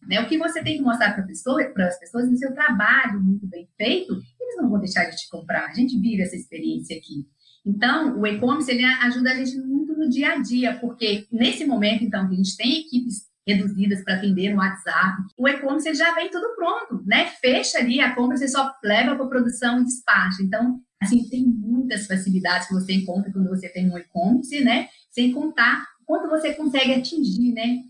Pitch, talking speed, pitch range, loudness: 240 Hz, 210 wpm, 195-265 Hz, -22 LUFS